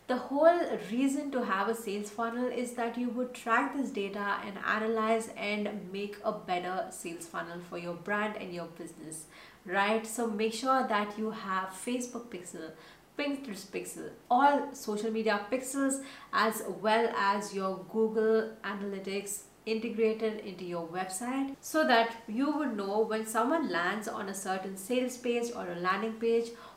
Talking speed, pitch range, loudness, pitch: 160 wpm, 195-245 Hz, -32 LUFS, 220 Hz